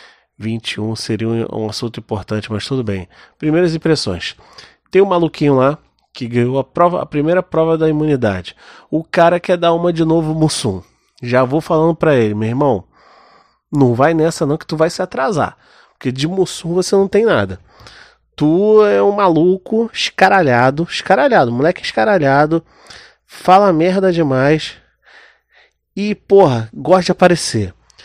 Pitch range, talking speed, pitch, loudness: 120-180 Hz, 150 wpm, 155 Hz, -15 LUFS